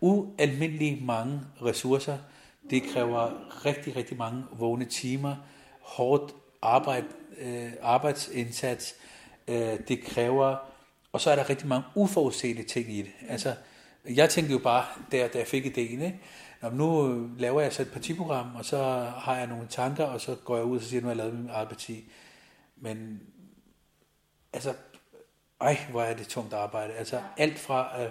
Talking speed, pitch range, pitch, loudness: 160 wpm, 120-145 Hz, 130 Hz, -30 LUFS